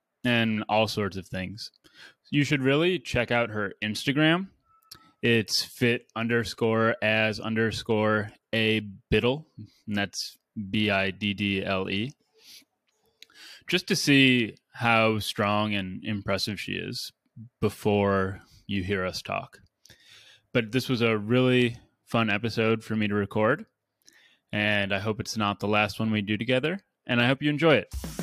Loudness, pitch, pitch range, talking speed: -26 LUFS, 110 Hz, 105-125 Hz, 135 wpm